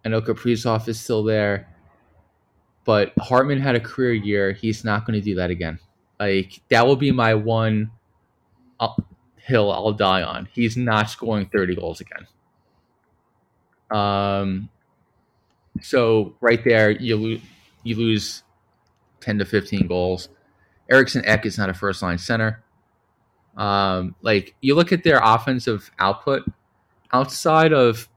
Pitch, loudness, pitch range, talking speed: 110 Hz, -20 LUFS, 100-115 Hz, 140 wpm